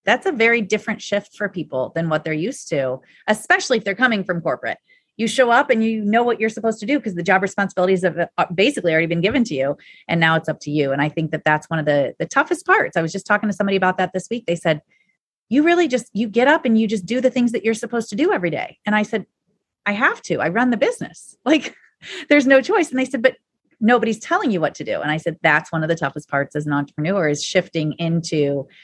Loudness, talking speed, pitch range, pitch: -19 LUFS, 265 wpm, 165-245 Hz, 205 Hz